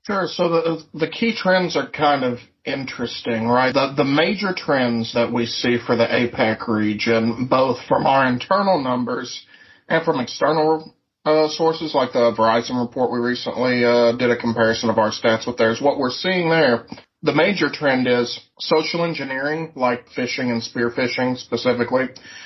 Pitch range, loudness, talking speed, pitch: 120-155 Hz, -20 LUFS, 170 wpm, 125 Hz